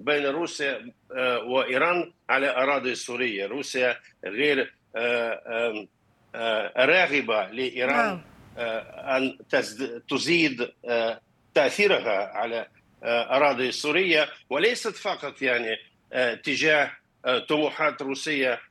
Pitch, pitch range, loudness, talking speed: 125 Hz, 120-140 Hz, -25 LUFS, 70 wpm